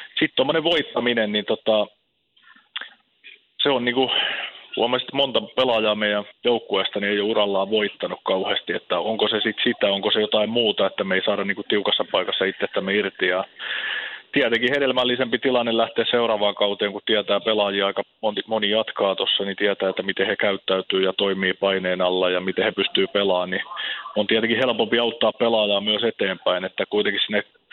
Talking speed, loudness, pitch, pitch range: 175 wpm, -21 LUFS, 105 Hz, 100-115 Hz